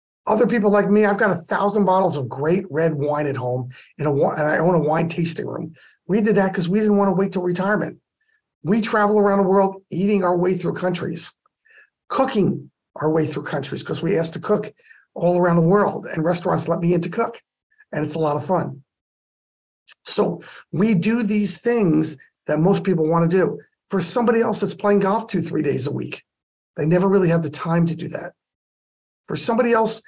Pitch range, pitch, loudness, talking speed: 160-205 Hz, 185 Hz, -20 LUFS, 210 wpm